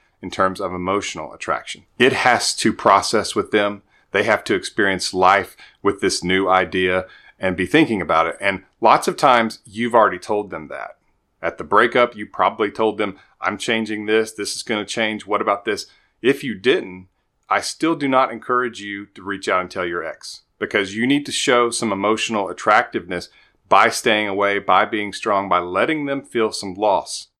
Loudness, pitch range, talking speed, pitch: -19 LUFS, 95-115 Hz, 195 wpm, 105 Hz